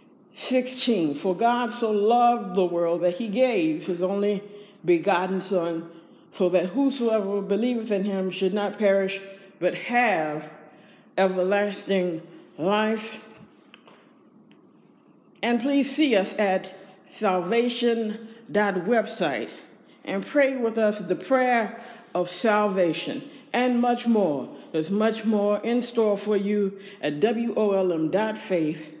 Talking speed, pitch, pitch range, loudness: 110 wpm, 205 Hz, 185-230 Hz, -25 LUFS